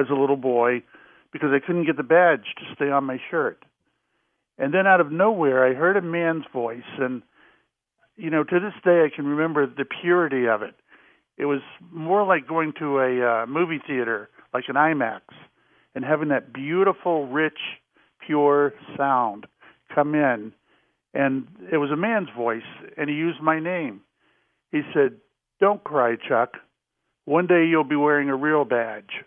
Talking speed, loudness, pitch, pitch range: 170 wpm, -22 LUFS, 150 Hz, 135-170 Hz